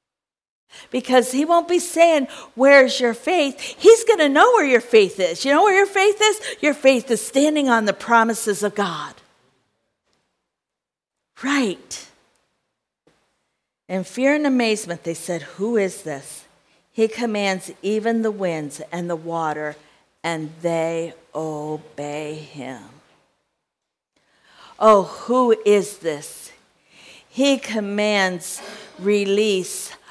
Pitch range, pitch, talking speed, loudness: 175-270 Hz, 215 Hz, 120 wpm, -19 LUFS